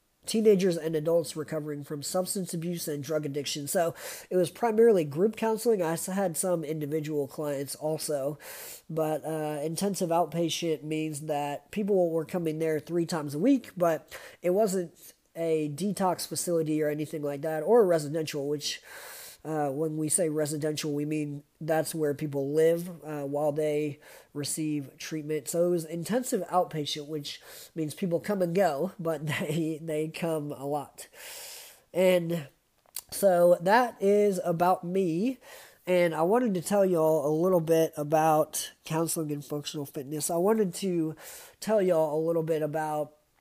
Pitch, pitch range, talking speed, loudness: 160 Hz, 150-180 Hz, 155 wpm, -28 LUFS